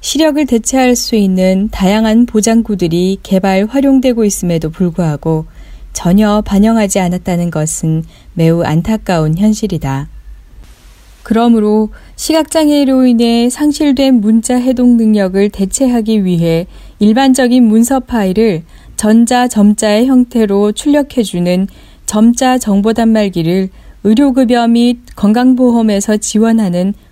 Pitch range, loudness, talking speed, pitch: 190-245 Hz, -11 LUFS, 275 characters per minute, 215 Hz